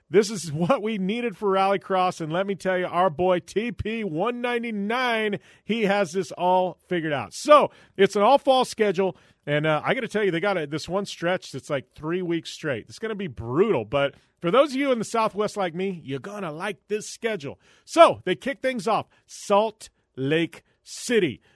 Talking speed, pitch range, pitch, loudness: 205 wpm, 170-215 Hz, 195 Hz, -24 LUFS